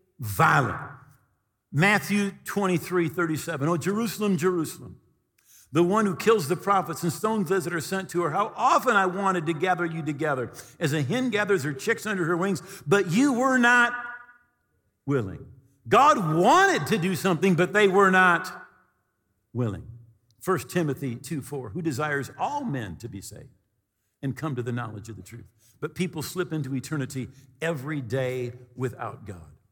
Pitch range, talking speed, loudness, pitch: 125-195 Hz, 165 wpm, -25 LUFS, 165 Hz